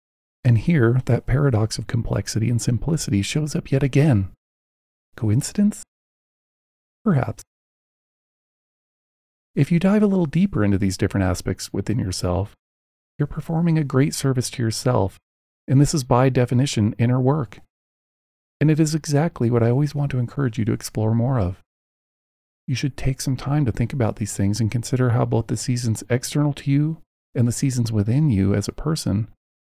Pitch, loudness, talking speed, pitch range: 125 Hz, -21 LUFS, 165 wpm, 105-145 Hz